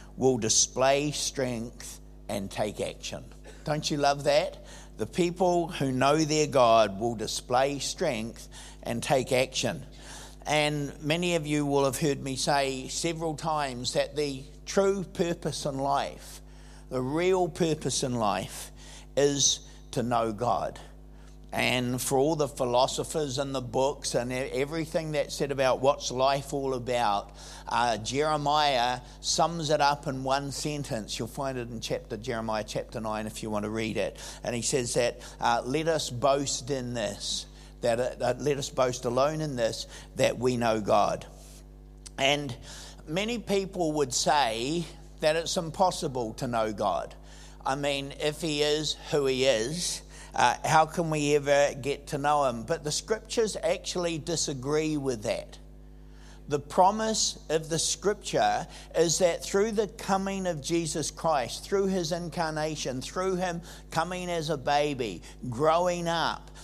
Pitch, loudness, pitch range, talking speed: 145 Hz, -28 LUFS, 130-165 Hz, 150 wpm